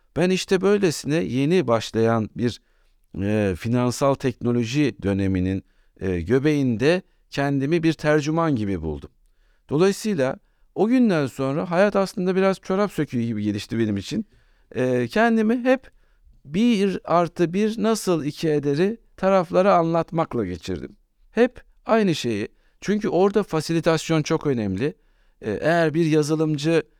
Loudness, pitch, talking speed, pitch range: -22 LUFS, 155 Hz, 120 wpm, 120-185 Hz